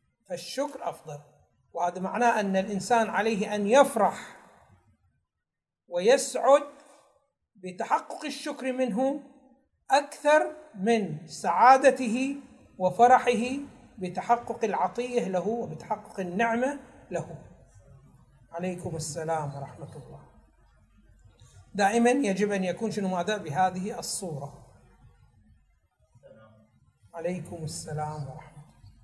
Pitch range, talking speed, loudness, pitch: 155-245 Hz, 80 wpm, -27 LUFS, 195 Hz